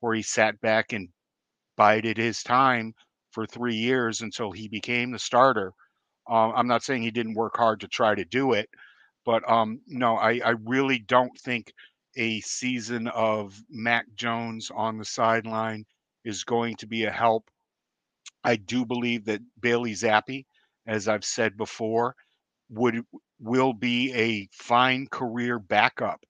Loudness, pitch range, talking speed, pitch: -25 LUFS, 110-120 Hz, 155 wpm, 115 Hz